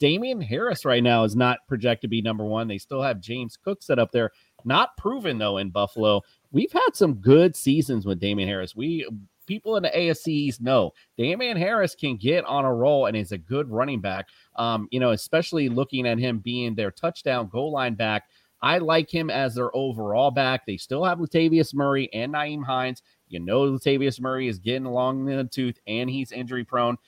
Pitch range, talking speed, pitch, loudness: 115-145 Hz, 205 wpm, 125 Hz, -24 LUFS